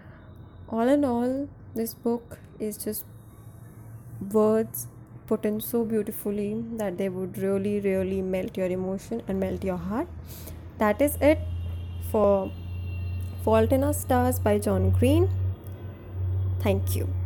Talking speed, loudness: 130 wpm, -27 LUFS